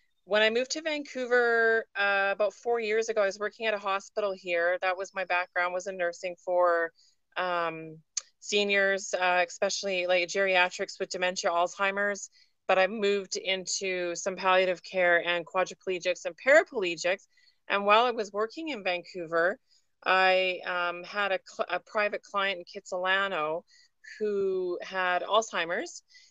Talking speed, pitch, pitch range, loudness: 150 wpm, 195 Hz, 180-215 Hz, -28 LUFS